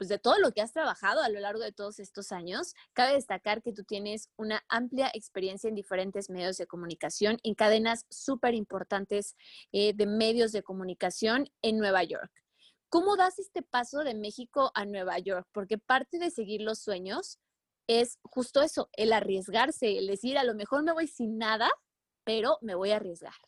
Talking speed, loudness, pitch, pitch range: 185 wpm, -30 LUFS, 220 Hz, 200-250 Hz